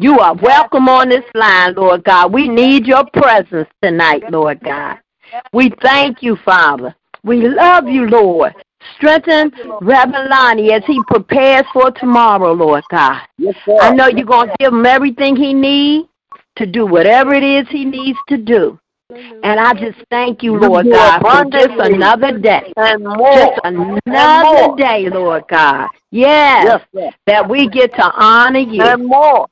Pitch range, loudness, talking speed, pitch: 220-275 Hz, -10 LUFS, 150 wpm, 255 Hz